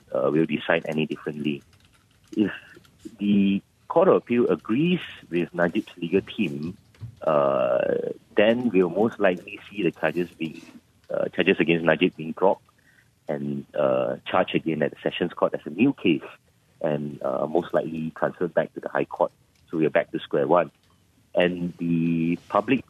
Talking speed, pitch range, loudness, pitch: 160 wpm, 80-95 Hz, -25 LUFS, 85 Hz